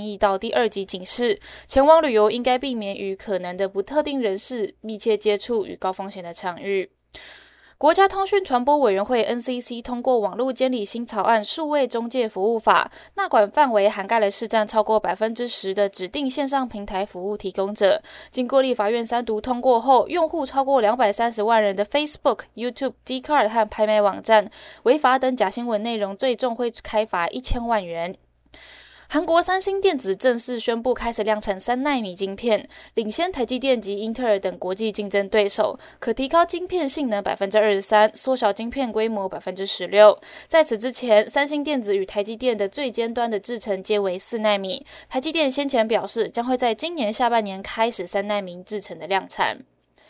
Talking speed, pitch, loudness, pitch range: 315 characters per minute, 230 Hz, -22 LUFS, 205-260 Hz